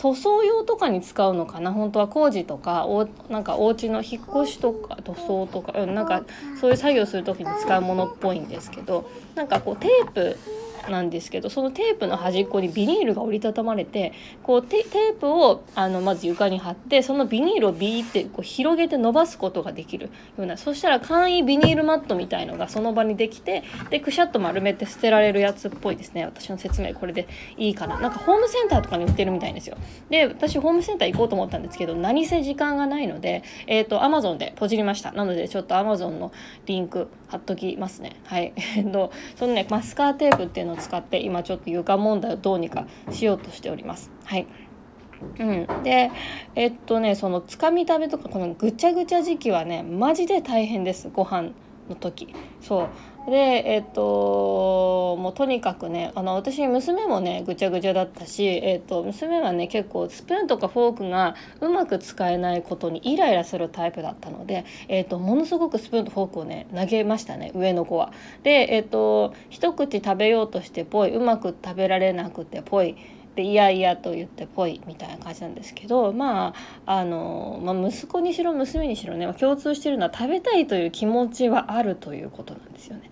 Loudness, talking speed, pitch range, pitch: -23 LUFS, 415 characters per minute, 185-275 Hz, 215 Hz